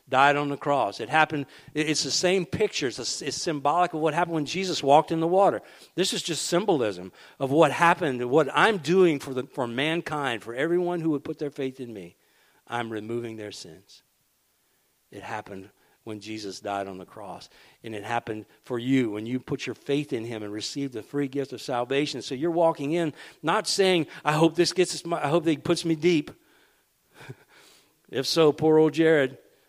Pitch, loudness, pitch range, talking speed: 145 Hz, -25 LUFS, 125-165 Hz, 200 wpm